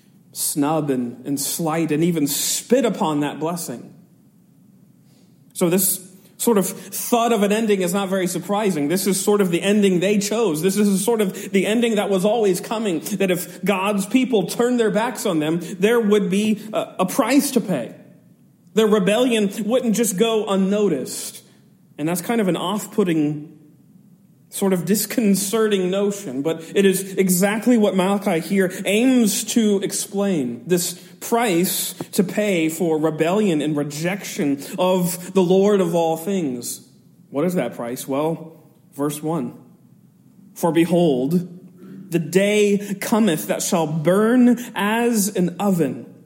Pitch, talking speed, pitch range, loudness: 195 Hz, 150 wpm, 170-210 Hz, -20 LUFS